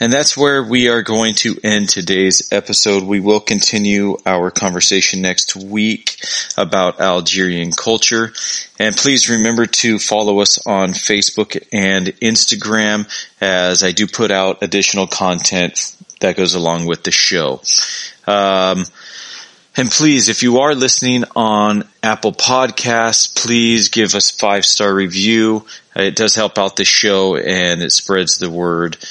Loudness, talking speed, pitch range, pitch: -13 LUFS, 145 wpm, 95-115 Hz, 100 Hz